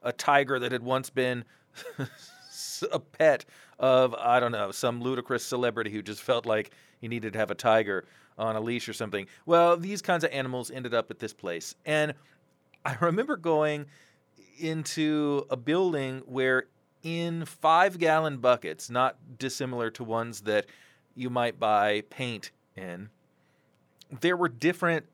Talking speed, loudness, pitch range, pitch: 155 wpm, -28 LUFS, 115-155 Hz, 130 Hz